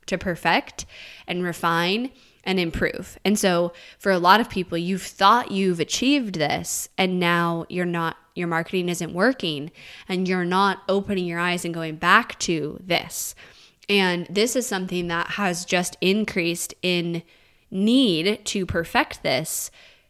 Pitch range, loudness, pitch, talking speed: 170-195 Hz, -23 LUFS, 180 Hz, 150 wpm